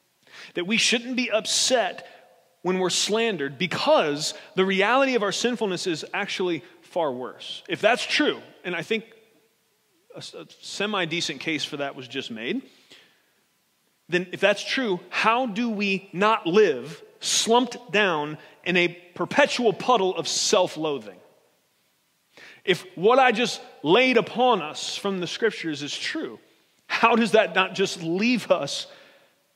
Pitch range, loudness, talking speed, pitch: 175-240 Hz, -23 LUFS, 140 wpm, 200 Hz